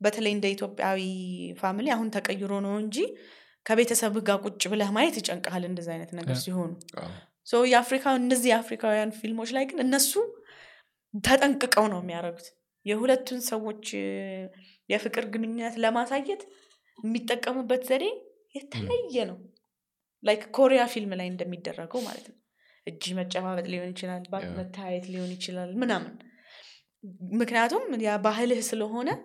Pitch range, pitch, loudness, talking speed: 185-250 Hz, 220 Hz, -28 LUFS, 110 wpm